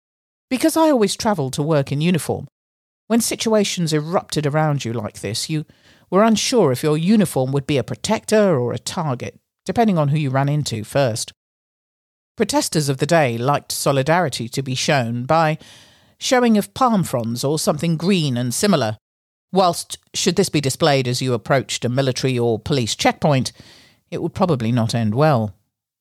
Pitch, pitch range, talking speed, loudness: 145 Hz, 120-180 Hz, 170 wpm, -19 LUFS